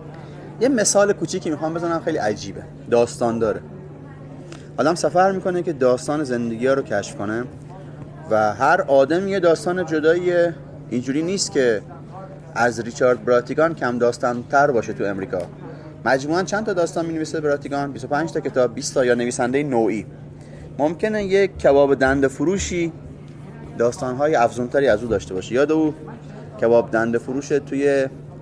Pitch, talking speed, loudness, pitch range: 140 Hz, 145 wpm, -20 LUFS, 125-165 Hz